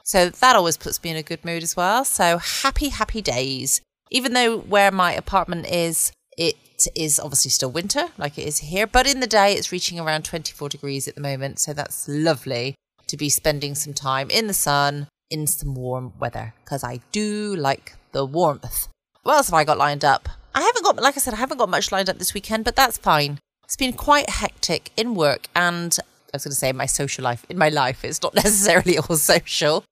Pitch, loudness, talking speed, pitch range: 165 Hz, -20 LUFS, 220 wpm, 145-205 Hz